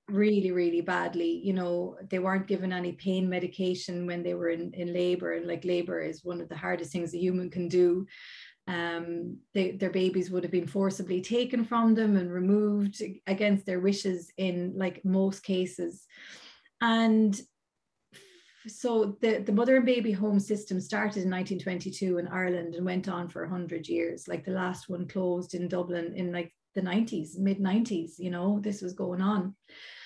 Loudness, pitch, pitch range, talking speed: -30 LUFS, 185 Hz, 175-200 Hz, 180 wpm